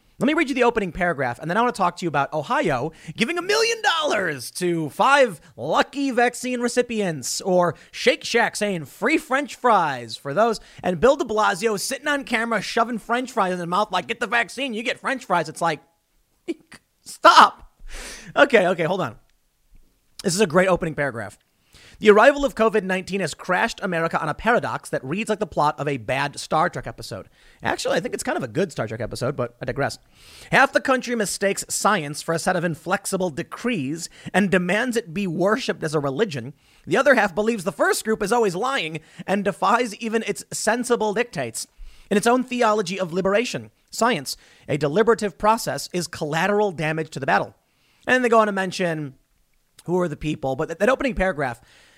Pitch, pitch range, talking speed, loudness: 195 Hz, 160-235 Hz, 195 wpm, -22 LUFS